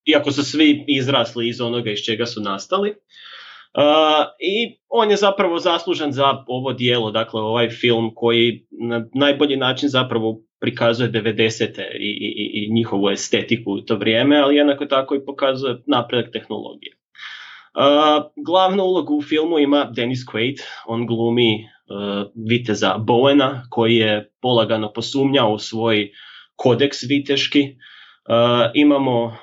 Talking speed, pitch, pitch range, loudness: 135 wpm, 120 Hz, 115-145 Hz, -18 LUFS